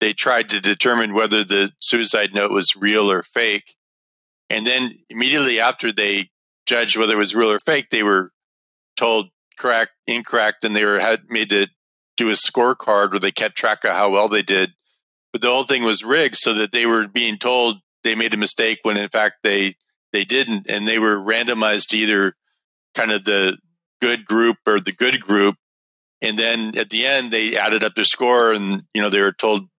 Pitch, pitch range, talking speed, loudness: 110 Hz, 100-115 Hz, 200 wpm, -17 LUFS